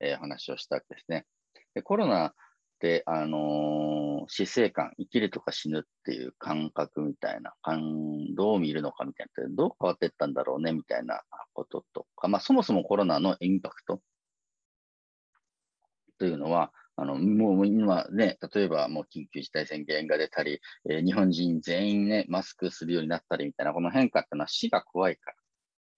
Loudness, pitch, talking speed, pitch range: -29 LUFS, 80 Hz, 355 characters per minute, 75-95 Hz